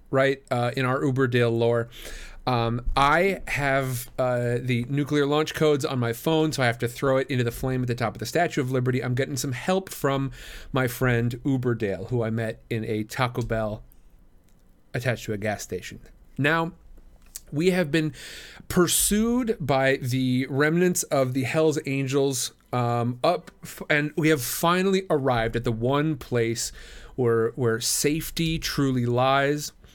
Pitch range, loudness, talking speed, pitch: 120-150 Hz, -25 LUFS, 165 wpm, 130 Hz